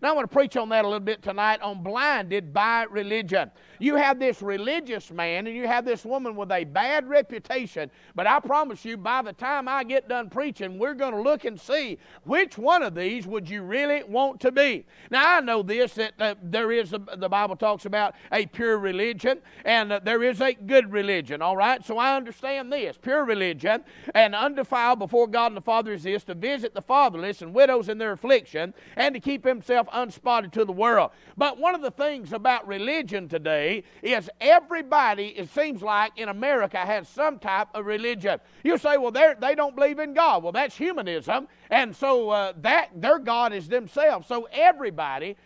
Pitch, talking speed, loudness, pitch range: 235 Hz, 200 wpm, -24 LUFS, 210-275 Hz